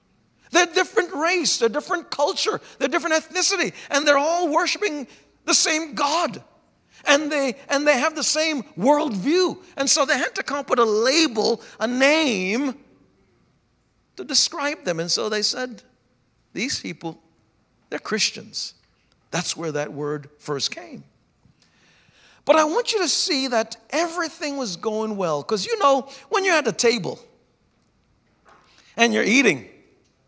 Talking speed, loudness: 150 wpm, -21 LUFS